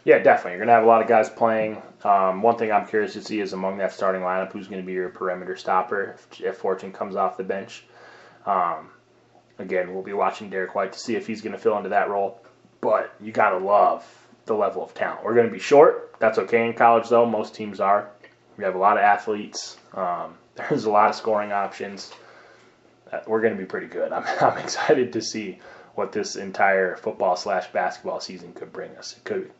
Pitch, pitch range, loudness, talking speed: 110 Hz, 95-115 Hz, -23 LUFS, 230 wpm